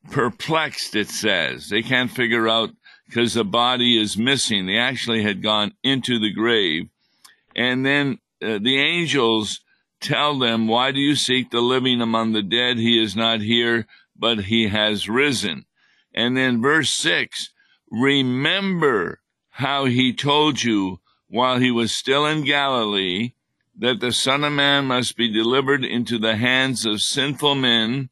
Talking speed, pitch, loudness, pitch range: 155 wpm, 120 Hz, -19 LUFS, 115-135 Hz